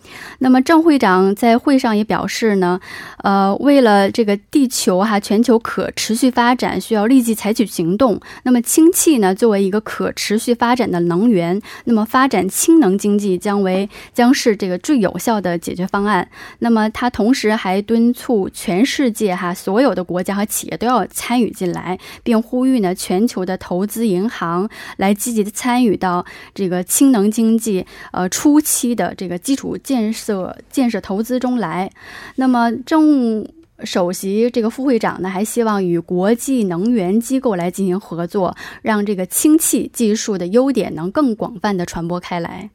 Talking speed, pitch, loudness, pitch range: 265 characters per minute, 215 Hz, -16 LUFS, 190-245 Hz